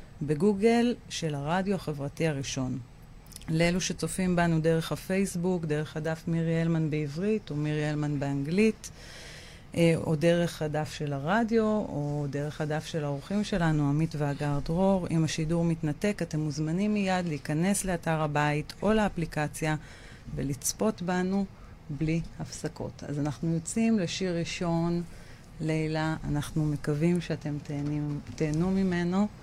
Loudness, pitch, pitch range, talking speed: -29 LUFS, 160 Hz, 150-180 Hz, 120 wpm